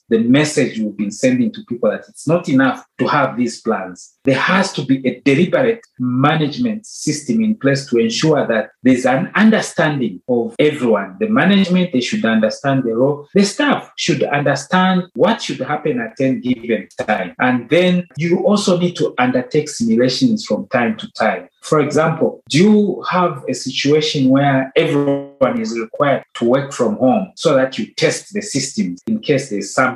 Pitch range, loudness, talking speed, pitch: 125-190 Hz, -16 LUFS, 180 wpm, 145 Hz